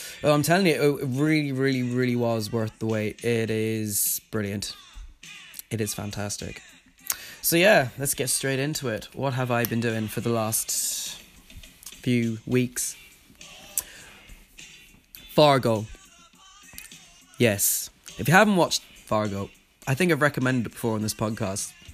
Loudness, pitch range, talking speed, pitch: -25 LUFS, 110-135 Hz, 140 wpm, 115 Hz